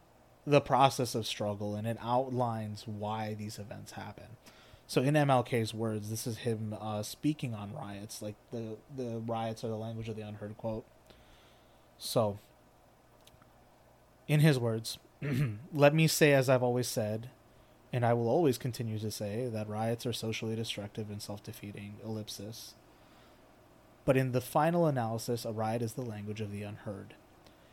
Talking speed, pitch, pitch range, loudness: 155 wpm, 115 Hz, 105-125 Hz, -33 LUFS